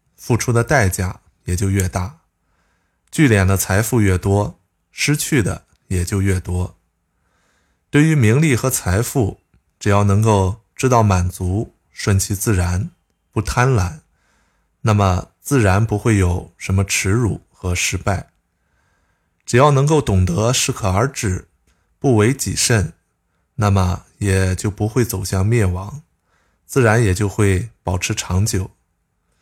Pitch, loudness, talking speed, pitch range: 95 Hz, -18 LUFS, 190 characters per minute, 90-115 Hz